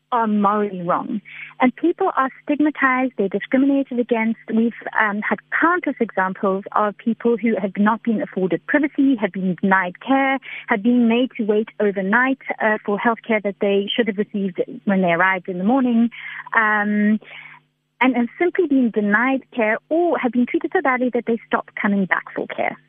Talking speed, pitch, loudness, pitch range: 180 wpm, 230 Hz, -20 LUFS, 205-260 Hz